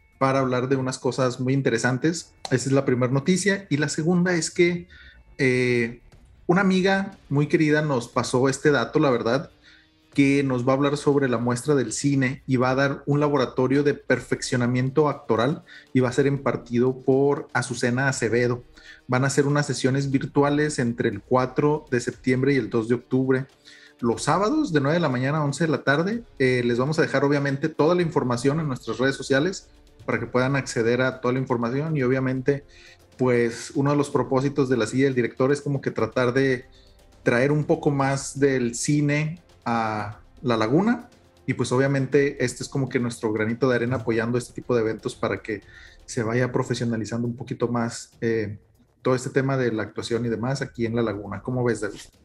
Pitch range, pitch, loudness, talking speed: 120-145 Hz, 130 Hz, -23 LUFS, 195 wpm